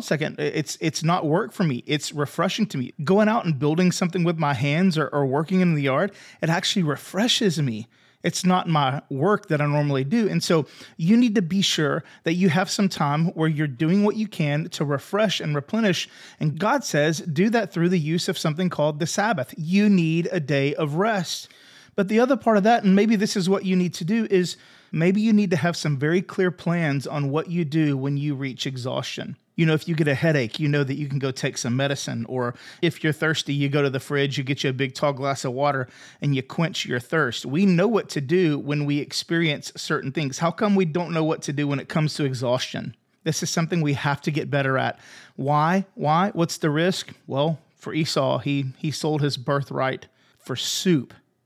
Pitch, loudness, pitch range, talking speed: 160 Hz, -23 LUFS, 145-185 Hz, 230 wpm